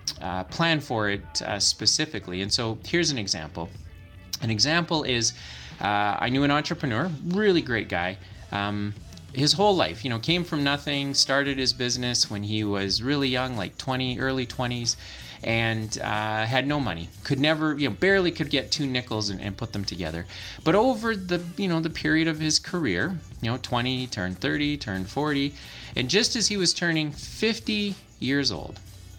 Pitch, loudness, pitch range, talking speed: 125 Hz, -25 LUFS, 100-150 Hz, 180 wpm